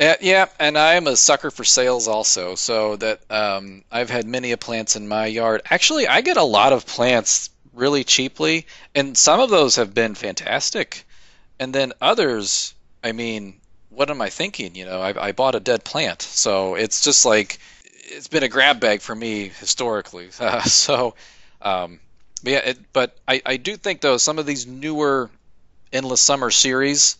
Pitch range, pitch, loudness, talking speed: 100-140 Hz, 115 Hz, -18 LUFS, 180 wpm